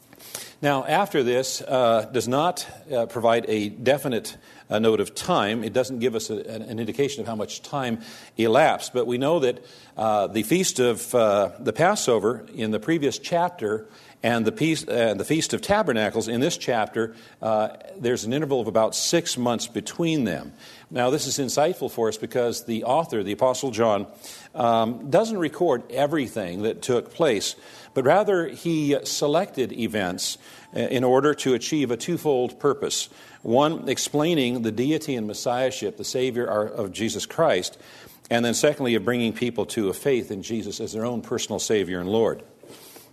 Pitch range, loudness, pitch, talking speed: 110-140 Hz, -24 LUFS, 120 Hz, 170 wpm